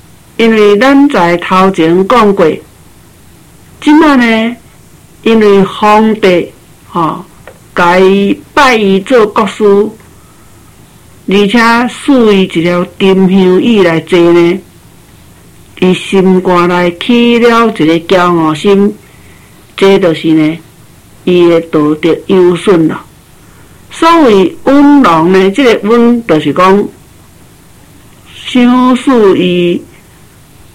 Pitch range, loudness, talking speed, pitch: 175-230 Hz, -7 LUFS, 140 characters per minute, 195 Hz